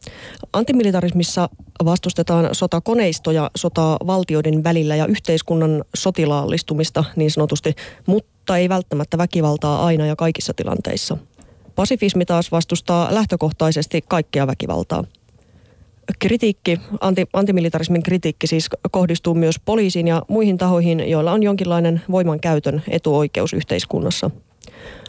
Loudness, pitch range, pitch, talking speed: -19 LUFS, 155-185 Hz, 170 Hz, 100 wpm